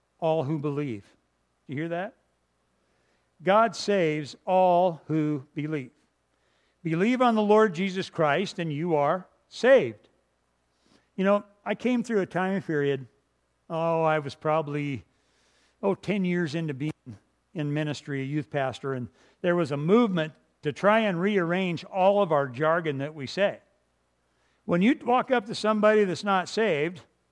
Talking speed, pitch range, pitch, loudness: 150 wpm, 130-190 Hz, 155 Hz, -26 LUFS